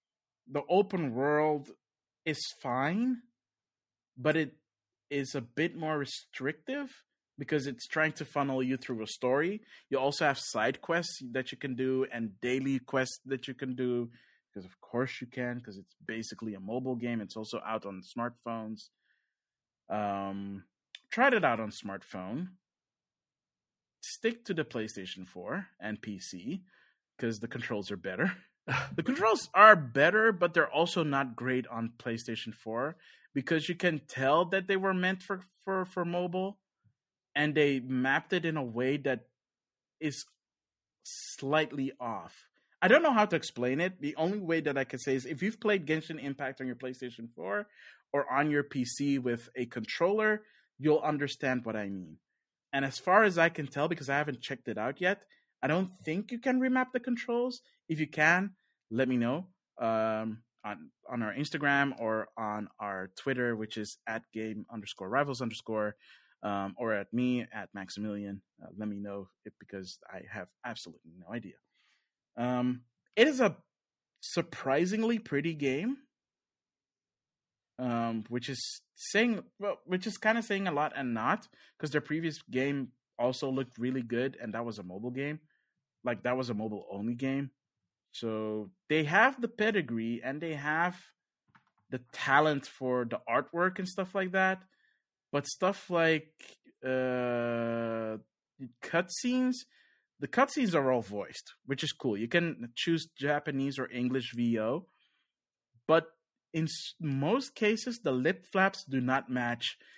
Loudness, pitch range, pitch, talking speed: -32 LUFS, 120-165 Hz, 135 Hz, 160 wpm